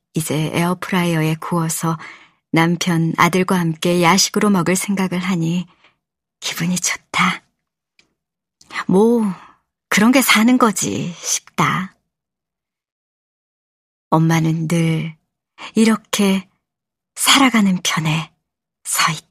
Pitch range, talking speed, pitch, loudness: 165-200 Hz, 190 characters per minute, 180 Hz, -17 LUFS